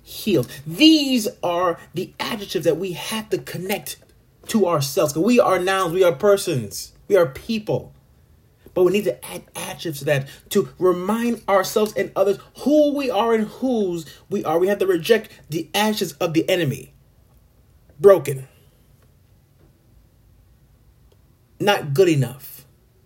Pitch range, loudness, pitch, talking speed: 130-200 Hz, -20 LUFS, 175 Hz, 140 wpm